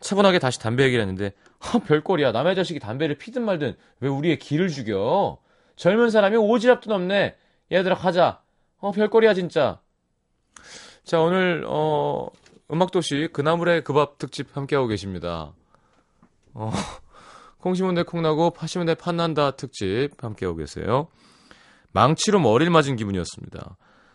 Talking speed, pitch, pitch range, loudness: 310 characters per minute, 160 Hz, 130-185 Hz, -22 LUFS